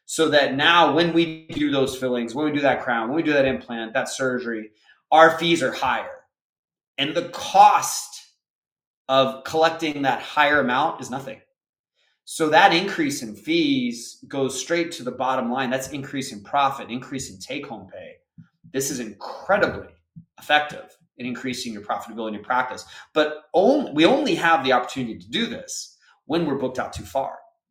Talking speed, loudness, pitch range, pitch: 175 wpm, -22 LUFS, 130-165 Hz, 140 Hz